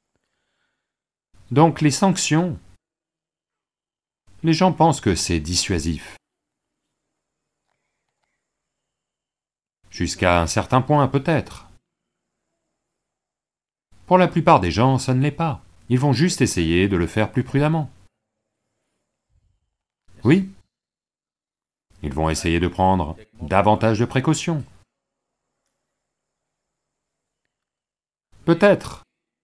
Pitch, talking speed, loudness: 115 Hz, 85 wpm, -19 LUFS